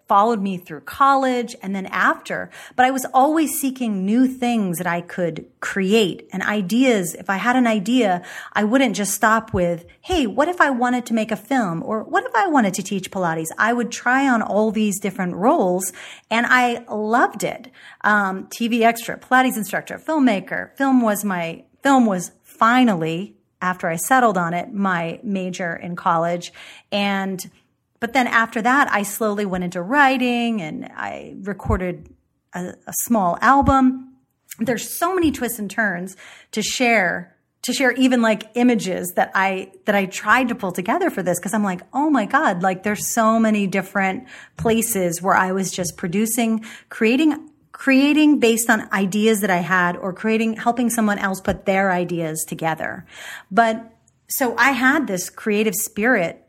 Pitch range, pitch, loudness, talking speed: 190-245 Hz, 215 Hz, -19 LUFS, 170 wpm